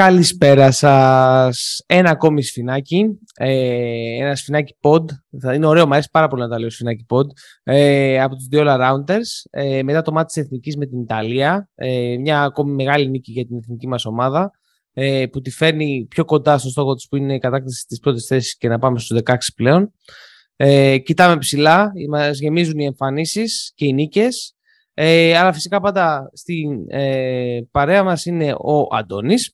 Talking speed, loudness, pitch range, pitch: 175 wpm, -16 LUFS, 130-160 Hz, 140 Hz